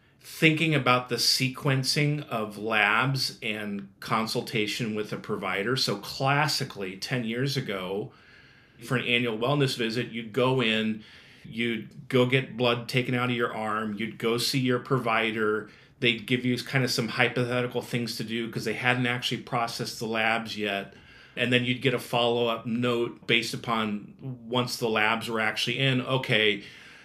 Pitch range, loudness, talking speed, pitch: 115-130 Hz, -27 LUFS, 160 wpm, 120 Hz